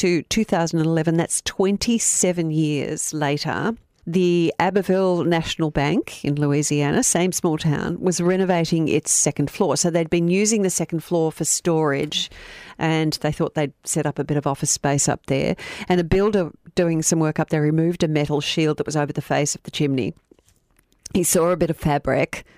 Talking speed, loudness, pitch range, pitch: 185 wpm, -21 LUFS, 150-180 Hz, 165 Hz